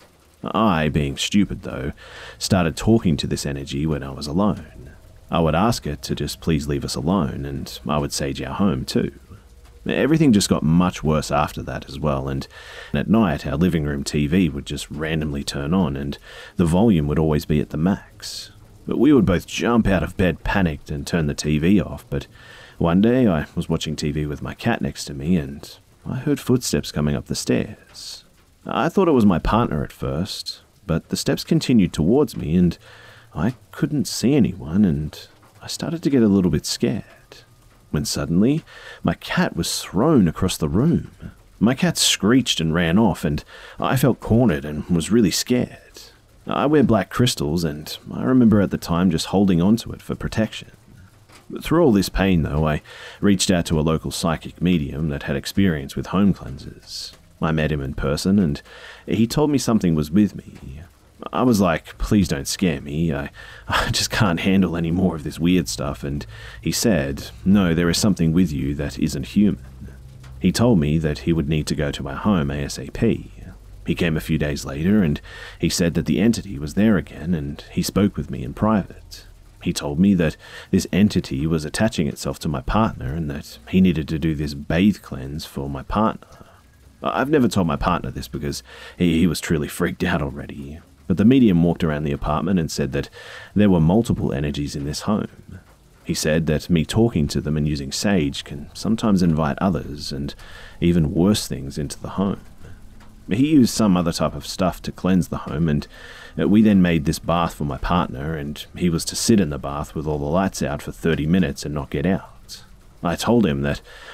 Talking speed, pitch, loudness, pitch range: 200 wpm, 80 Hz, -21 LUFS, 70-95 Hz